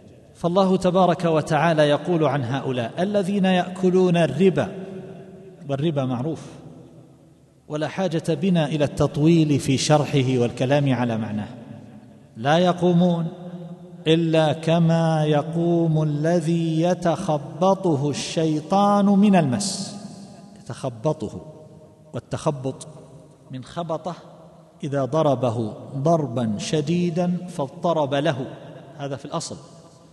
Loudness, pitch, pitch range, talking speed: -21 LUFS, 160 Hz, 145-175 Hz, 90 wpm